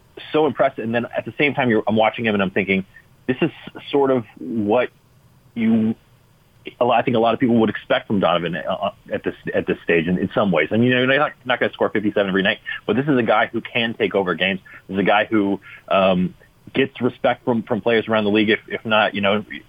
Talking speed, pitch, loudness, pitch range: 255 wpm, 115 Hz, -20 LUFS, 105-130 Hz